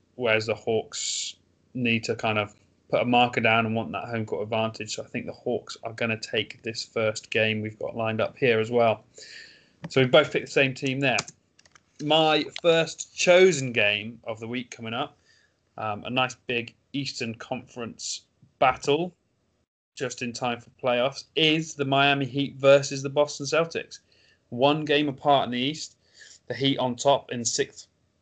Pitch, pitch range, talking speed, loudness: 125 Hz, 115-140 Hz, 180 wpm, -25 LUFS